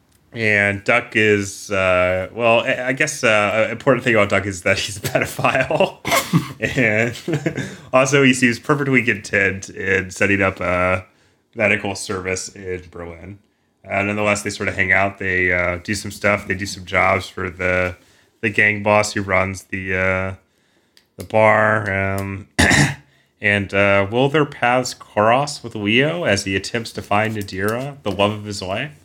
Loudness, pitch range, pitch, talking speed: -18 LUFS, 95-115 Hz, 100 Hz, 165 wpm